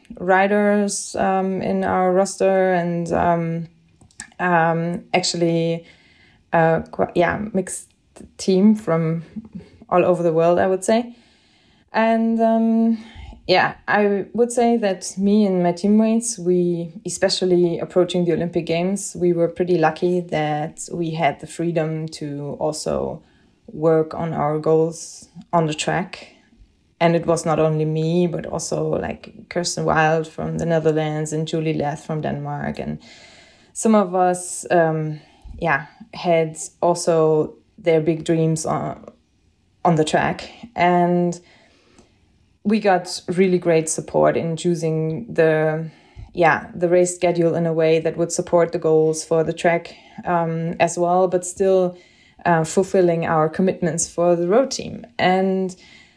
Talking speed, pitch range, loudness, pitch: 135 wpm, 160-185 Hz, -20 LUFS, 170 Hz